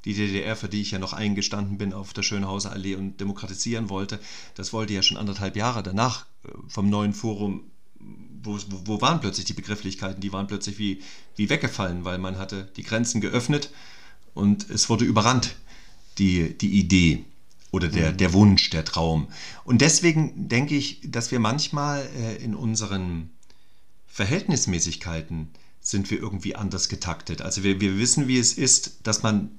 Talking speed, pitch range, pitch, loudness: 165 wpm, 95-115 Hz, 100 Hz, -24 LUFS